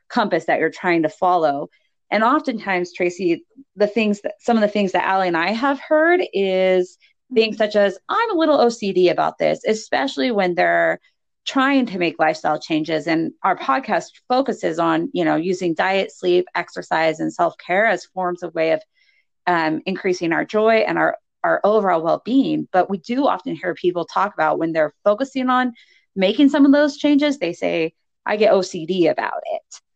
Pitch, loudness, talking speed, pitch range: 195 Hz, -19 LUFS, 185 wpm, 175-265 Hz